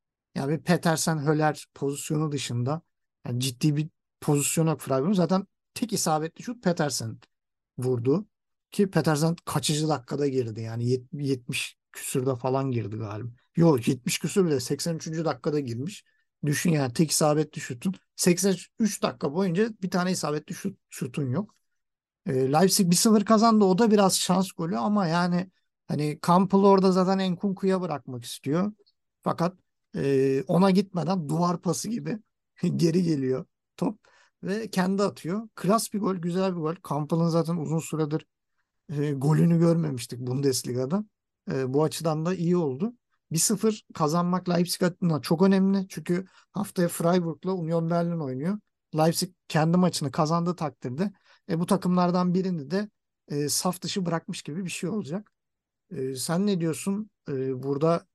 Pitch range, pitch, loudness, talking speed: 150-190 Hz, 170 Hz, -26 LUFS, 140 wpm